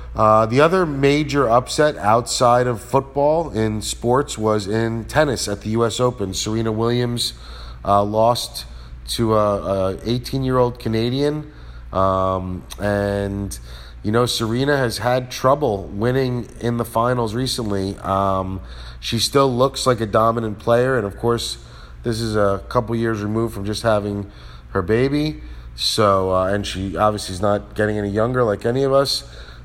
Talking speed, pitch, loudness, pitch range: 155 wpm, 110 Hz, -19 LUFS, 95-125 Hz